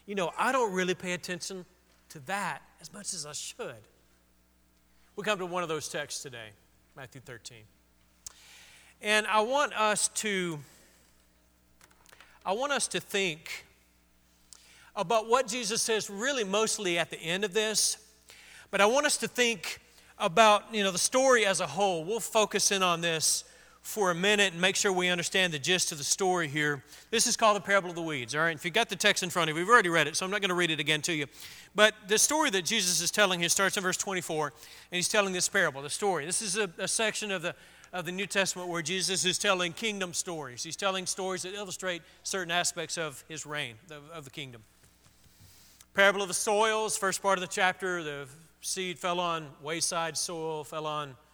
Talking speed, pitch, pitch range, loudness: 210 wpm, 180 Hz, 155-200 Hz, -28 LUFS